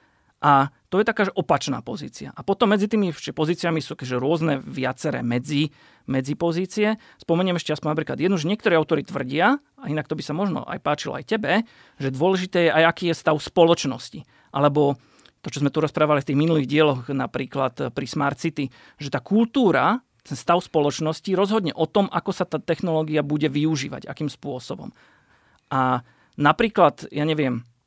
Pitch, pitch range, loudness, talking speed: 155 Hz, 140-180 Hz, -23 LUFS, 170 wpm